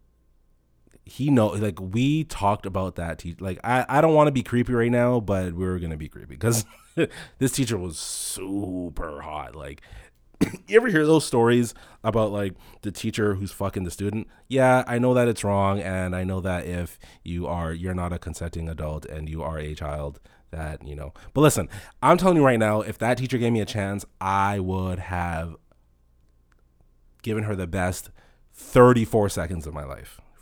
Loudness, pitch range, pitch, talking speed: -24 LUFS, 85-115 Hz, 95 Hz, 185 wpm